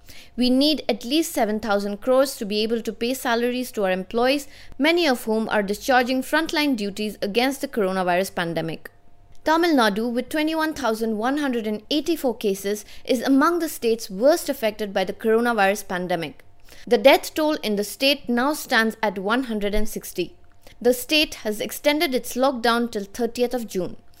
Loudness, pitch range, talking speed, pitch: -22 LUFS, 210-275 Hz, 150 wpm, 235 Hz